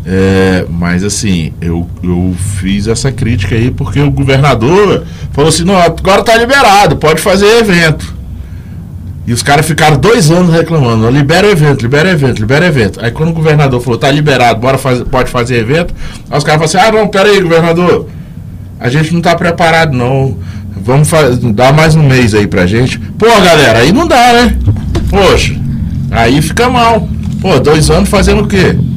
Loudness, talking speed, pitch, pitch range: -8 LUFS, 185 wpm, 135 Hz, 105-165 Hz